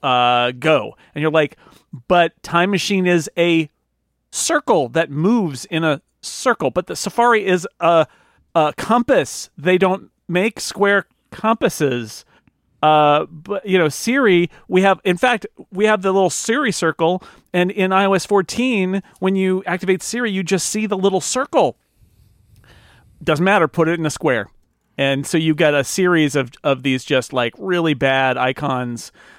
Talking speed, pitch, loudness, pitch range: 160 wpm, 170 Hz, -18 LUFS, 140-195 Hz